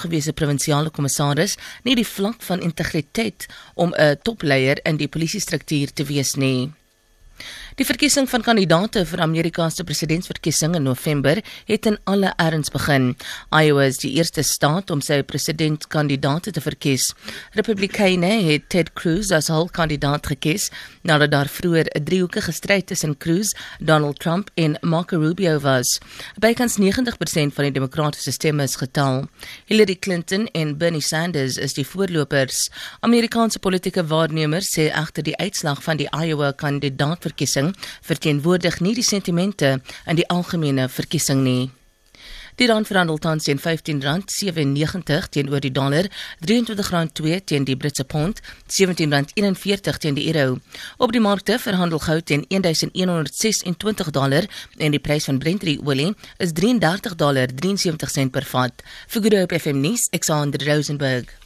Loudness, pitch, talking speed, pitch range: -20 LUFS, 160 Hz, 140 wpm, 145-185 Hz